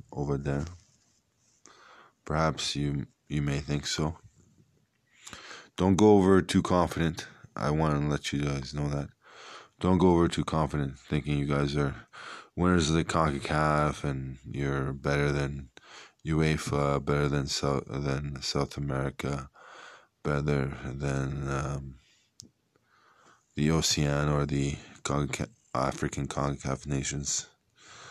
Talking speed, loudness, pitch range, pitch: 120 wpm, -29 LUFS, 70-80 Hz, 70 Hz